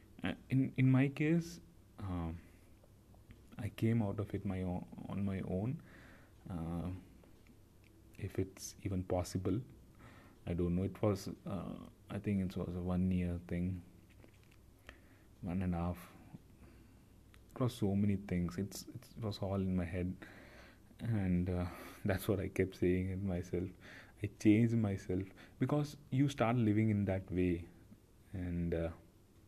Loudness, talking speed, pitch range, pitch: -38 LUFS, 145 wpm, 90-105 Hz, 95 Hz